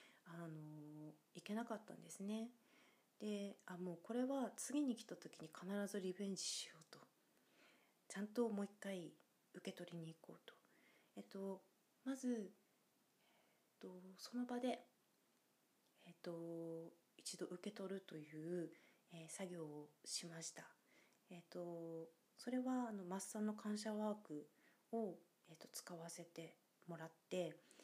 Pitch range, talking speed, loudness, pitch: 170-215 Hz, 250 characters per minute, -50 LUFS, 190 Hz